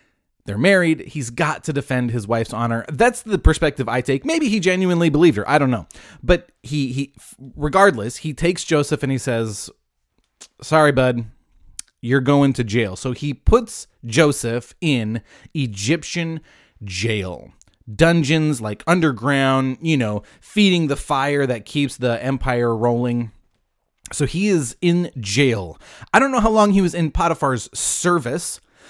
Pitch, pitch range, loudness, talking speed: 135 Hz, 120-165 Hz, -19 LUFS, 150 wpm